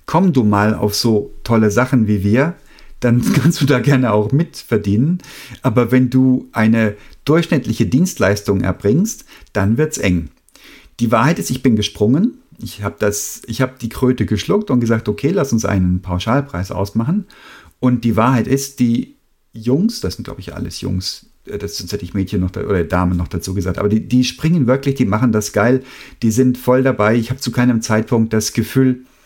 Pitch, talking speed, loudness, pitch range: 120 Hz, 185 wpm, -16 LUFS, 105-130 Hz